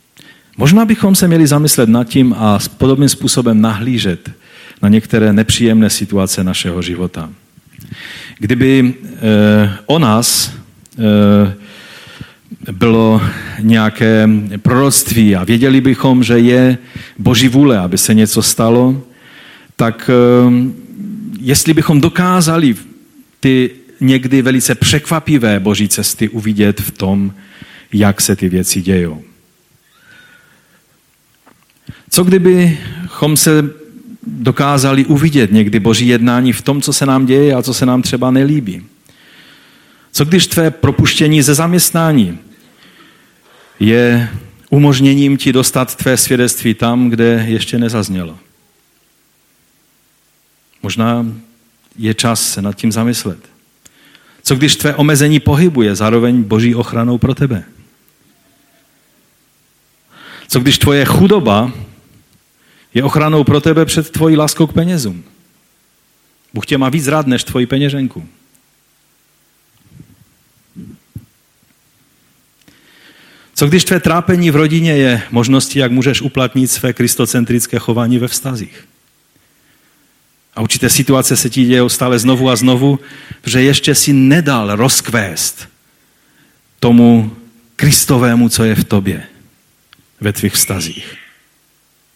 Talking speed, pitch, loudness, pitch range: 110 wpm, 125 Hz, -11 LUFS, 110-145 Hz